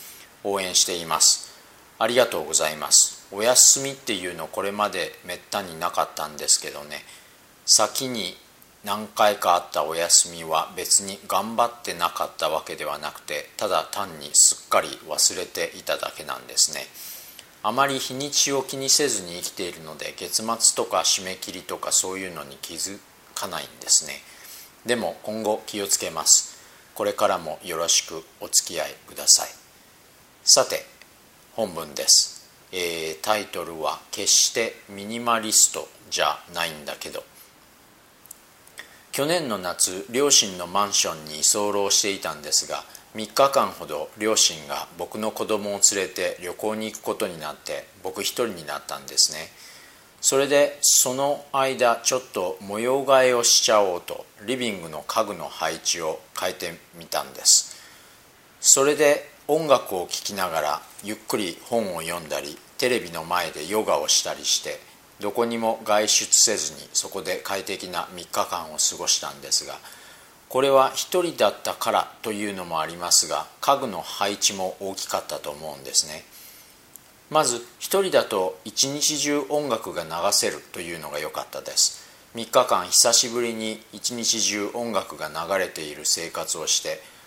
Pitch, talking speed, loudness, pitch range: 110 Hz, 295 characters per minute, -22 LUFS, 100-135 Hz